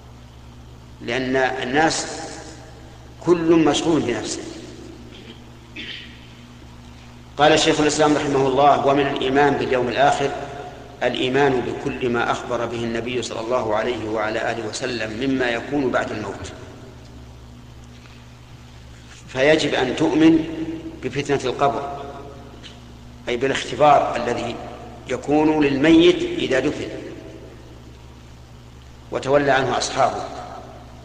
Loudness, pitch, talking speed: -20 LUFS, 115 Hz, 85 wpm